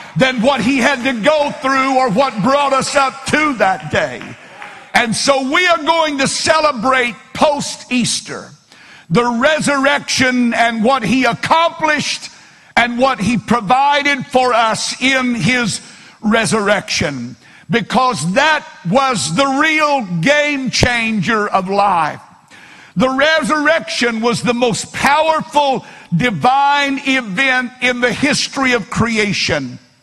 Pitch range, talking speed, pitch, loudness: 225-280 Hz, 120 wpm, 255 Hz, -14 LUFS